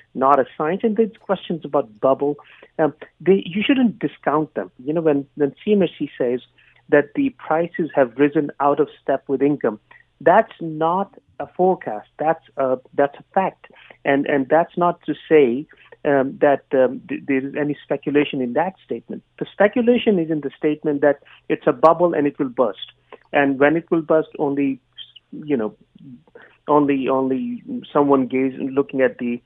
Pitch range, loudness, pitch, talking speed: 140-175 Hz, -20 LUFS, 150 Hz, 170 wpm